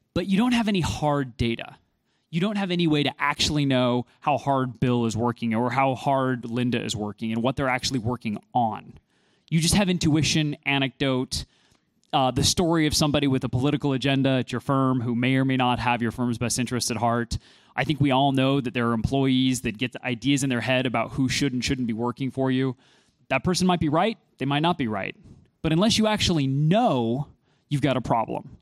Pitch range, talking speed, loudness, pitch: 125-150 Hz, 220 wpm, -24 LUFS, 130 Hz